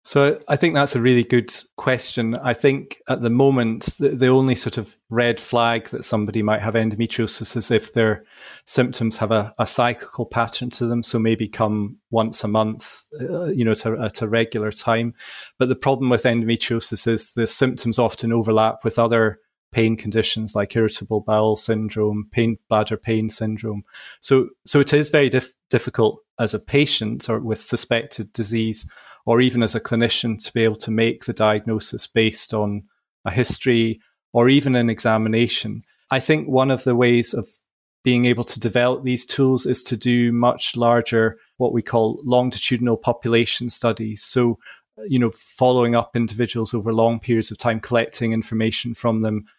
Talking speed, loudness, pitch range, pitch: 175 wpm, -19 LUFS, 110-125 Hz, 115 Hz